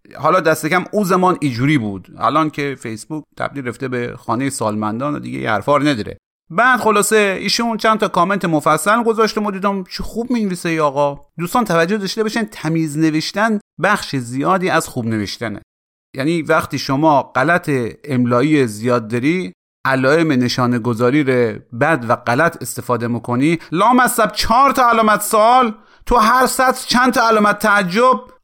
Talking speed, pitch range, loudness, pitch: 155 wpm, 130-210 Hz, -16 LUFS, 160 Hz